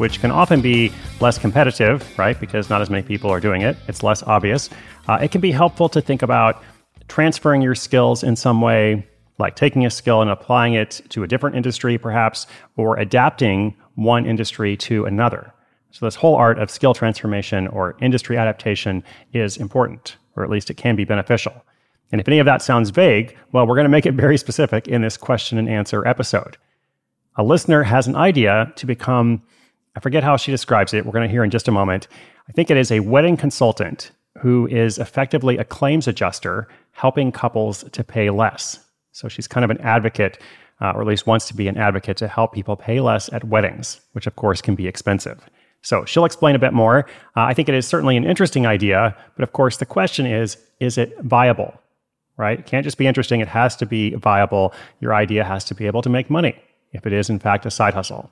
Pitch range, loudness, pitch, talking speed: 105-130 Hz, -18 LUFS, 115 Hz, 215 wpm